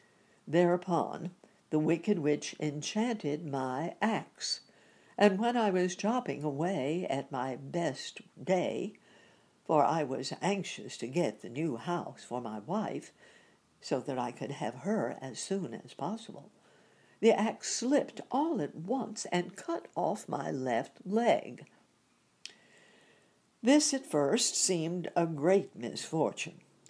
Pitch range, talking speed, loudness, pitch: 155-215 Hz, 130 wpm, -32 LUFS, 185 Hz